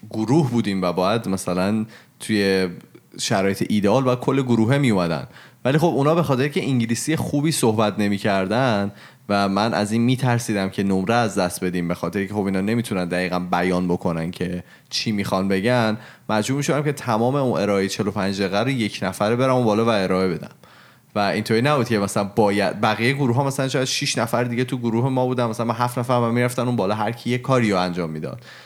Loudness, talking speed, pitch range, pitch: -21 LUFS, 195 wpm, 100-125 Hz, 110 Hz